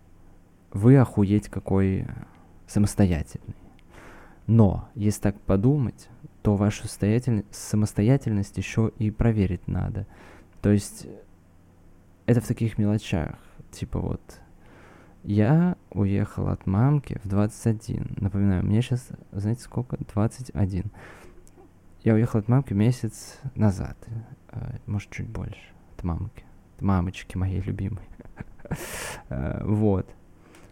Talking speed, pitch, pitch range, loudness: 100 wpm, 105 Hz, 90-115 Hz, -25 LUFS